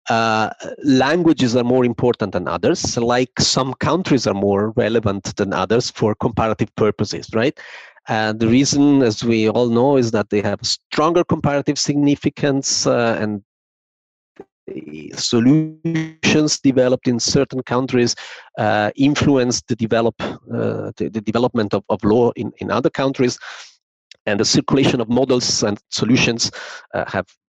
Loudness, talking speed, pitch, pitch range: -18 LUFS, 140 wpm, 120 Hz, 110-135 Hz